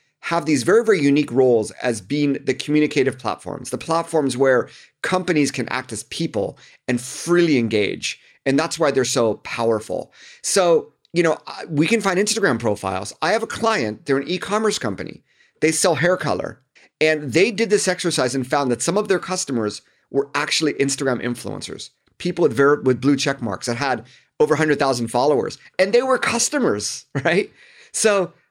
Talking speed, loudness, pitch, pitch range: 175 wpm, -20 LUFS, 145 Hz, 125-180 Hz